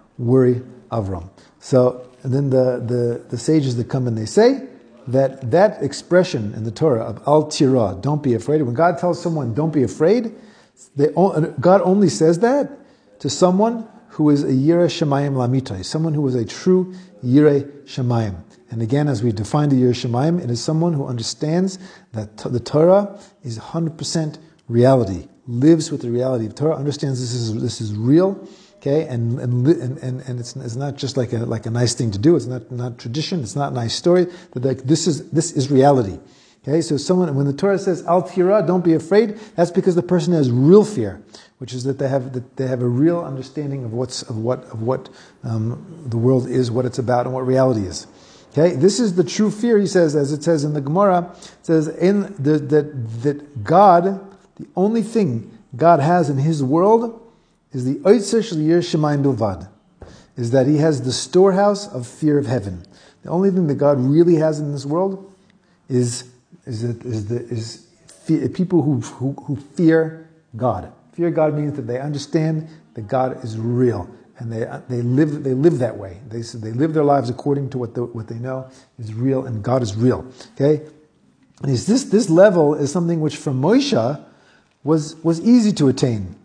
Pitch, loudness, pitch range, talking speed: 145 Hz, -19 LUFS, 125-170 Hz, 195 wpm